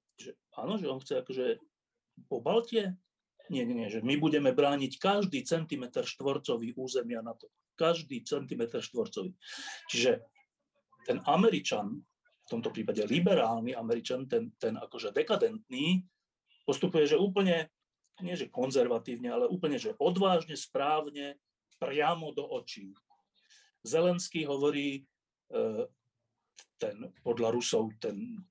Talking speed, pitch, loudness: 115 wpm, 195 Hz, -32 LUFS